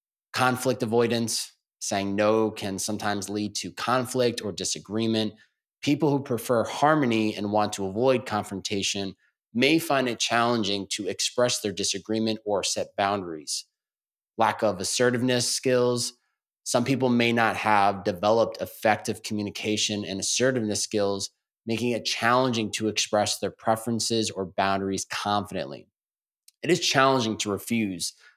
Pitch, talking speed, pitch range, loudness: 110 Hz, 130 wpm, 105-125 Hz, -25 LUFS